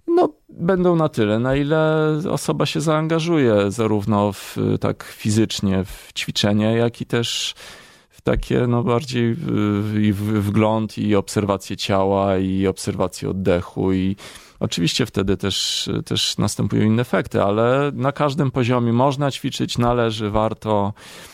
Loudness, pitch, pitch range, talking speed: -20 LUFS, 110 Hz, 100-125 Hz, 130 wpm